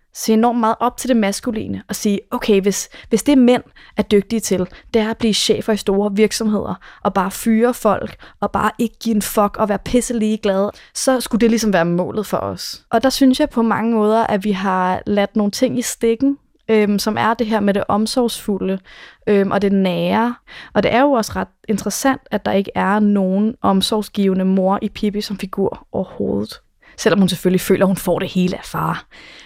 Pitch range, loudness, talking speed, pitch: 195-230 Hz, -18 LUFS, 210 wpm, 210 Hz